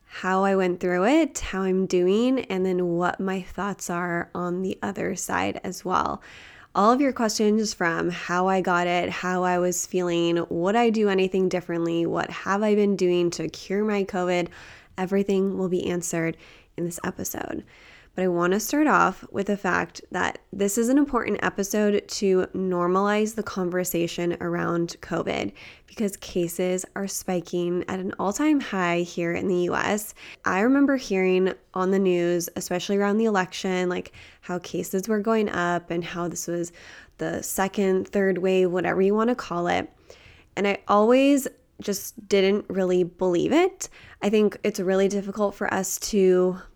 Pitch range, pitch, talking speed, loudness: 175-205 Hz, 185 Hz, 170 wpm, -24 LUFS